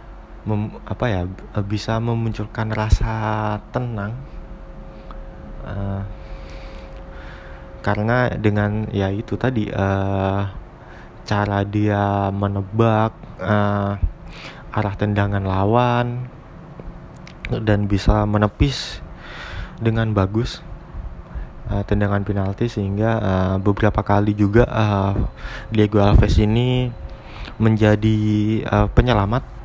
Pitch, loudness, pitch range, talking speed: 105 Hz, -20 LUFS, 100-110 Hz, 85 wpm